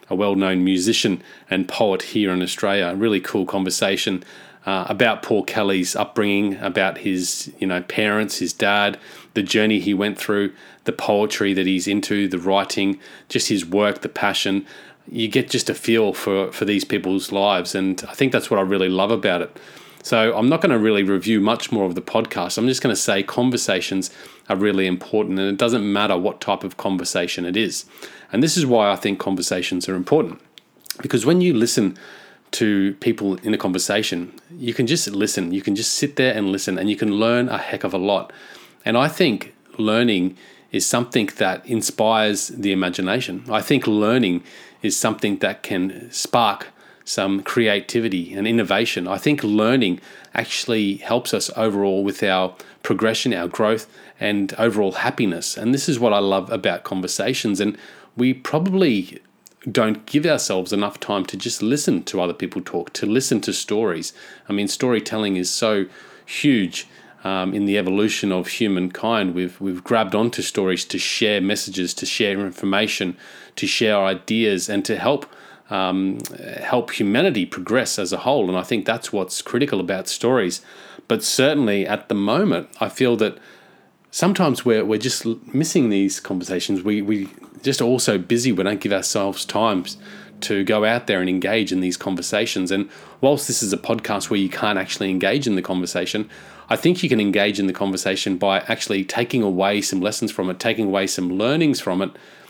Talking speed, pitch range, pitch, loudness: 180 wpm, 95-110 Hz, 100 Hz, -20 LUFS